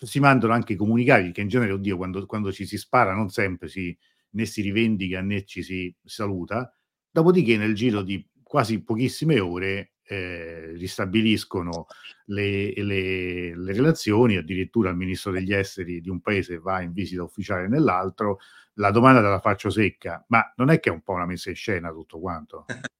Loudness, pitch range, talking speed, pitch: -24 LUFS, 90-110 Hz, 175 wpm, 100 Hz